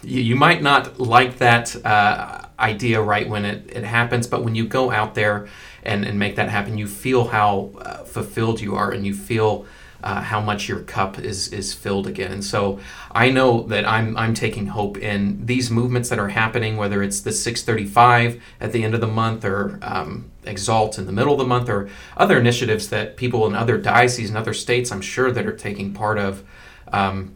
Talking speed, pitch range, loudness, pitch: 210 wpm, 100-120 Hz, -20 LUFS, 110 Hz